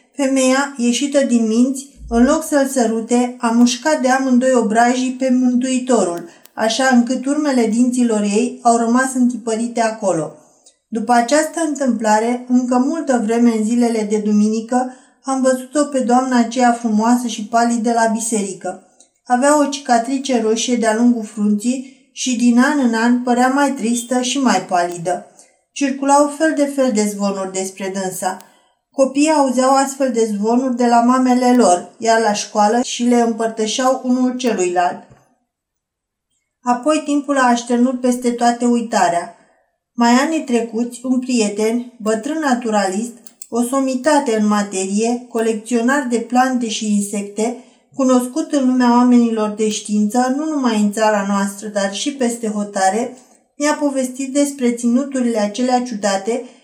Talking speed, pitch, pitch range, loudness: 140 wpm, 240 Hz, 220-260 Hz, -16 LUFS